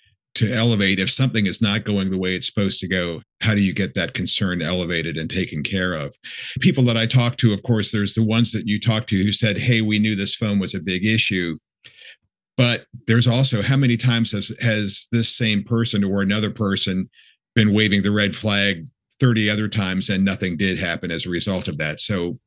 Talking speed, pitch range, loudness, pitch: 215 wpm, 95-115 Hz, -18 LUFS, 105 Hz